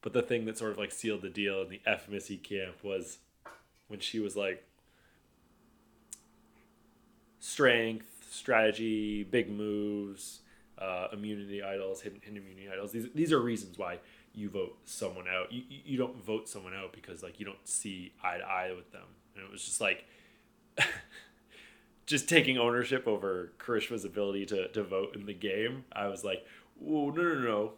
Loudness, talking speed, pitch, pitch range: -34 LUFS, 175 wpm, 105 Hz, 100-115 Hz